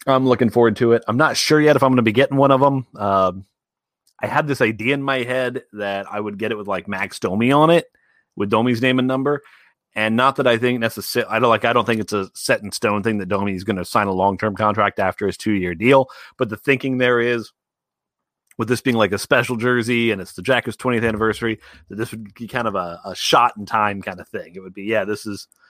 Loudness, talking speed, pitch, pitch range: -19 LUFS, 265 wpm, 115 Hz, 105-130 Hz